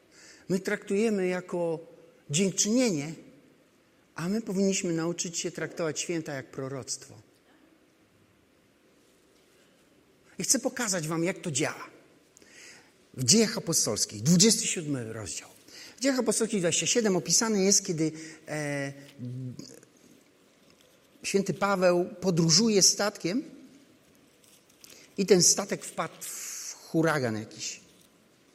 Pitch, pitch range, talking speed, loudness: 180 Hz, 160-205 Hz, 90 wpm, -27 LUFS